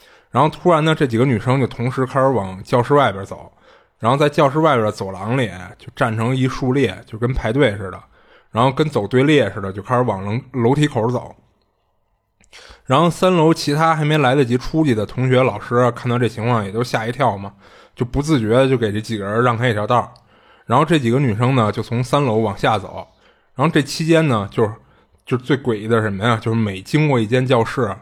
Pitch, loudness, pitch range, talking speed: 125 Hz, -18 LUFS, 110-140 Hz, 315 characters per minute